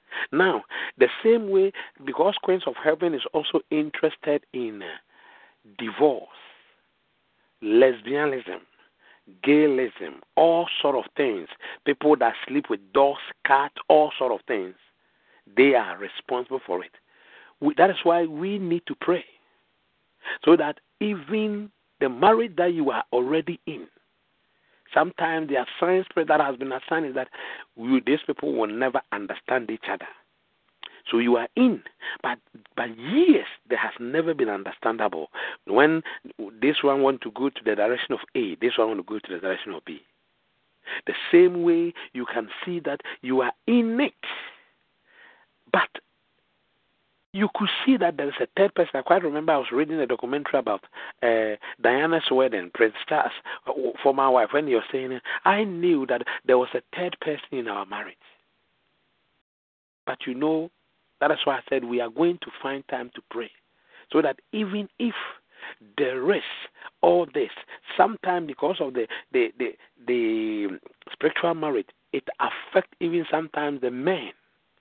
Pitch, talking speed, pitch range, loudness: 165 Hz, 155 wpm, 135-210 Hz, -24 LUFS